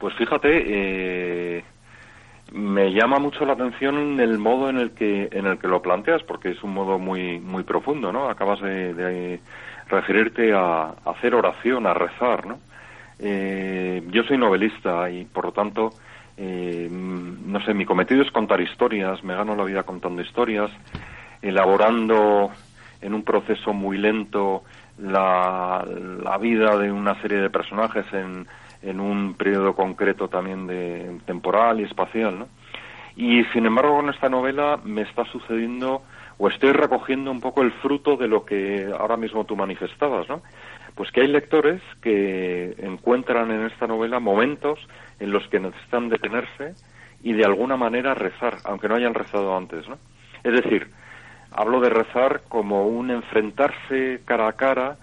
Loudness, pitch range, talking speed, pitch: -22 LUFS, 95-120 Hz, 160 wpm, 105 Hz